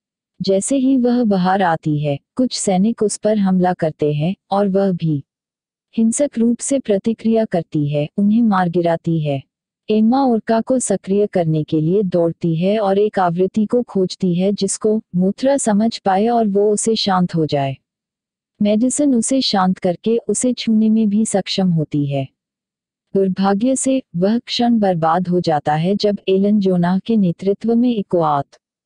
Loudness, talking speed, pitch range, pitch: -17 LUFS, 160 wpm, 180-225 Hz, 200 Hz